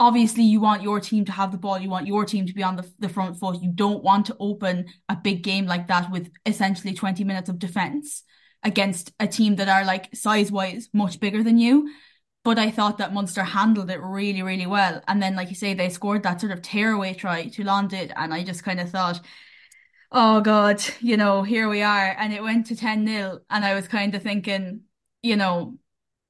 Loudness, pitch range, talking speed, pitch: -23 LUFS, 190-215 Hz, 225 wpm, 200 Hz